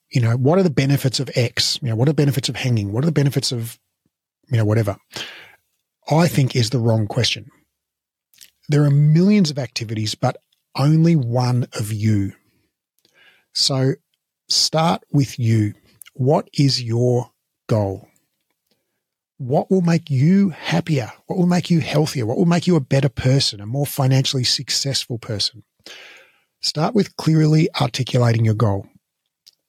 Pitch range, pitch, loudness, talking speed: 115-150 Hz, 135 Hz, -19 LUFS, 155 wpm